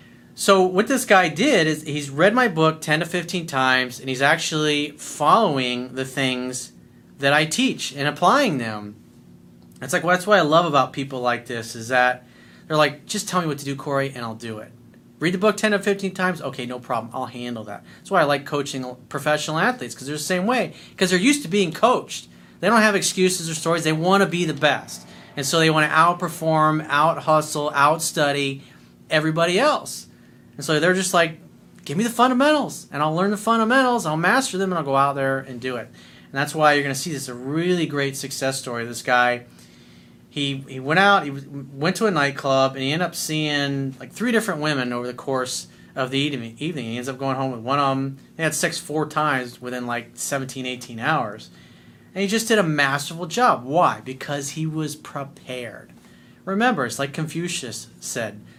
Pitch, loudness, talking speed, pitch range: 145 Hz, -21 LUFS, 210 wpm, 130-175 Hz